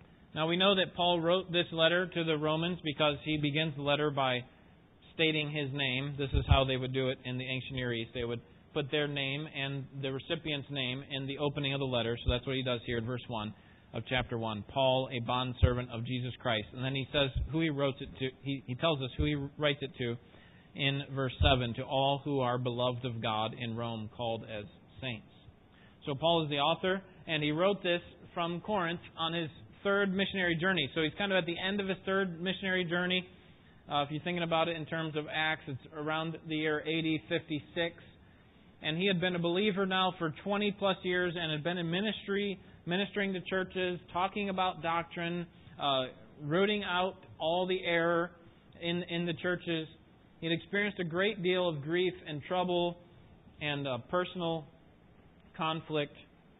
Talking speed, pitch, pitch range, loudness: 200 wpm, 155 Hz, 135-175 Hz, -33 LUFS